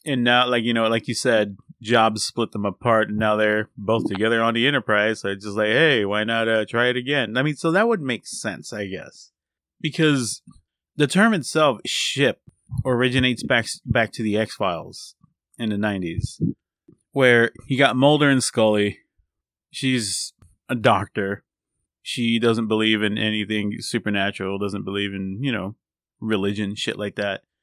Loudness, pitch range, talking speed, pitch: -21 LUFS, 105-125 Hz, 170 wpm, 110 Hz